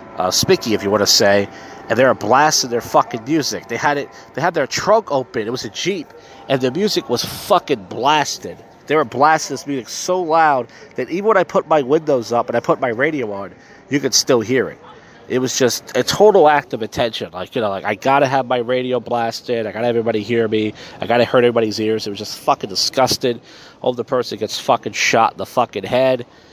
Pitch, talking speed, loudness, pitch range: 125 Hz, 230 wpm, -17 LUFS, 115-140 Hz